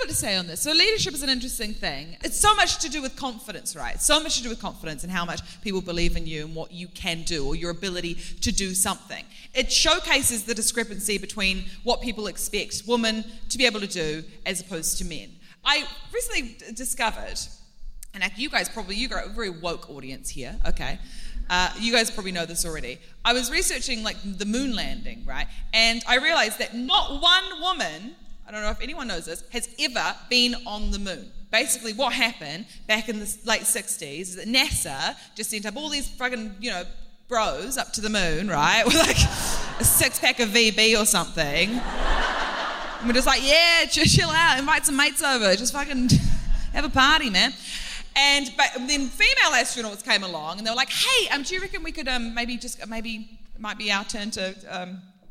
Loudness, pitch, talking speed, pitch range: -23 LUFS, 225 Hz, 205 wpm, 190-255 Hz